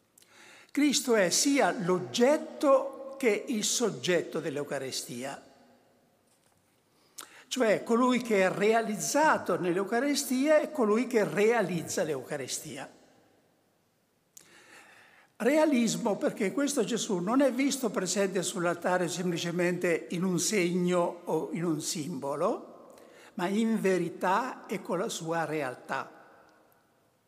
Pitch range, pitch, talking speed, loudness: 180-265 Hz, 215 Hz, 95 wpm, -29 LUFS